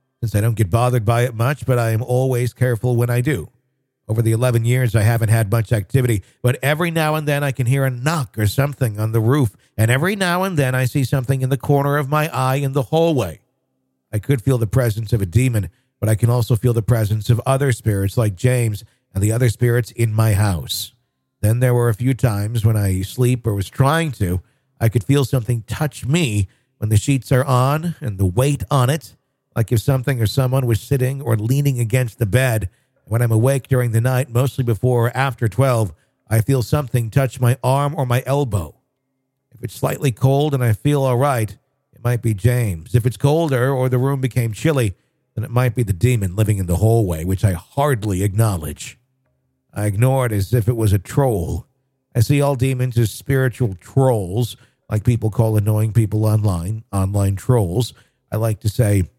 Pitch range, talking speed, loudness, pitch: 110-135 Hz, 210 wpm, -19 LUFS, 125 Hz